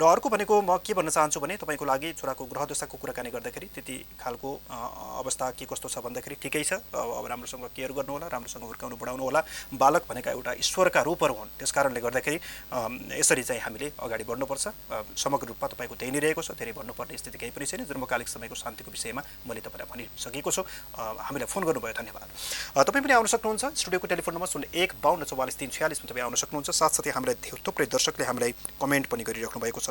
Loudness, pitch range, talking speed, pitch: -29 LUFS, 130-185 Hz, 200 wpm, 150 Hz